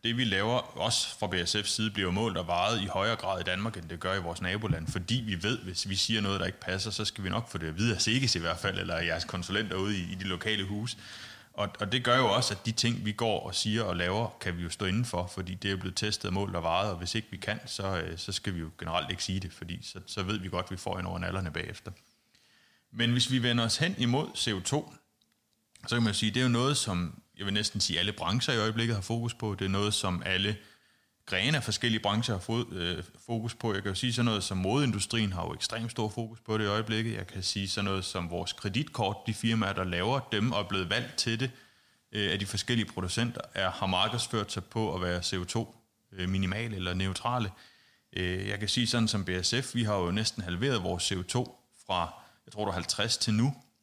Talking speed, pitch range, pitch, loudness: 250 wpm, 95-115 Hz, 105 Hz, -31 LUFS